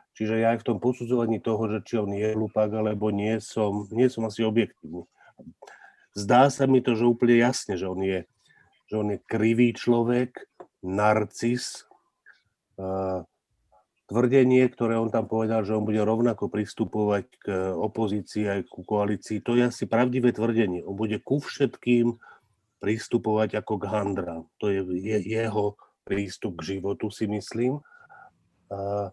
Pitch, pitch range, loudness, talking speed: 110 Hz, 100-120 Hz, -26 LUFS, 145 wpm